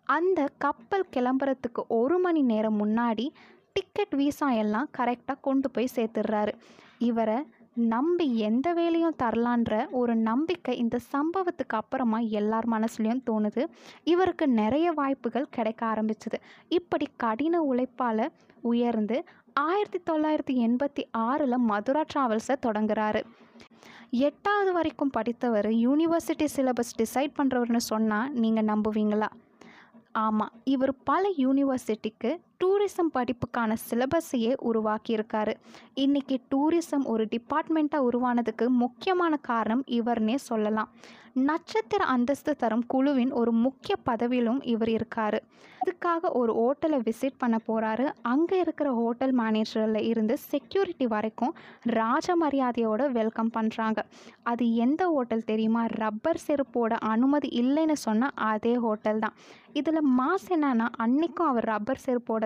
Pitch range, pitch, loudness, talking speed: 225-290 Hz, 245 Hz, -27 LUFS, 110 wpm